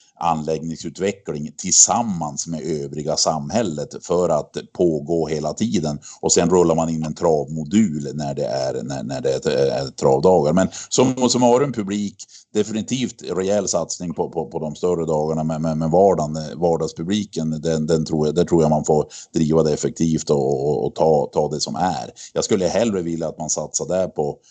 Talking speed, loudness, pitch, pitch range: 185 wpm, -20 LUFS, 80 Hz, 80-100 Hz